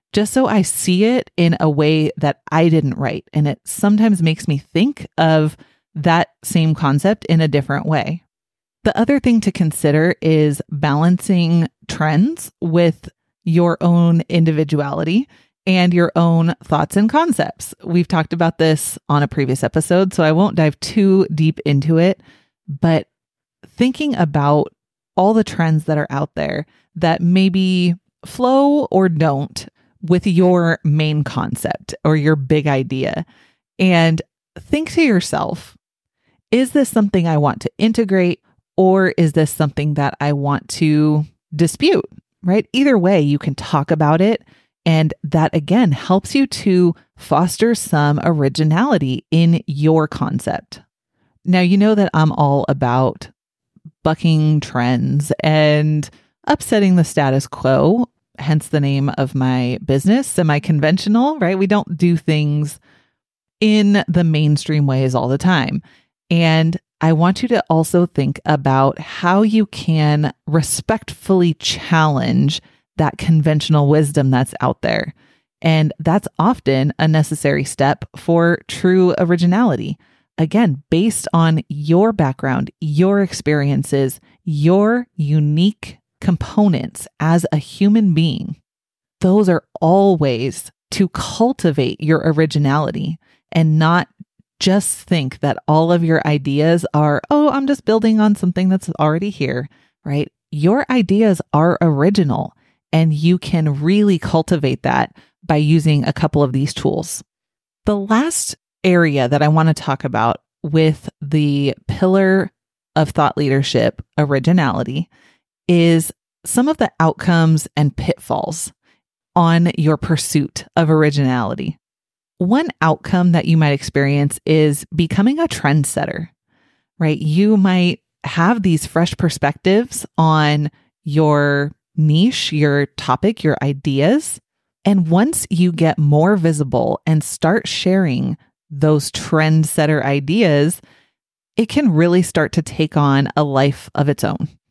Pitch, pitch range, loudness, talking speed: 160 Hz, 150-185 Hz, -16 LUFS, 135 wpm